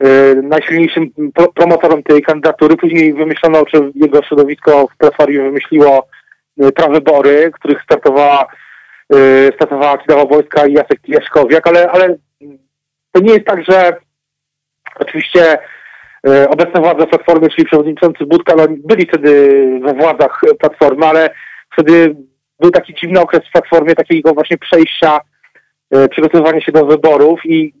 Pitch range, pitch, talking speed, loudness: 145-165 Hz, 155 Hz, 125 wpm, -9 LUFS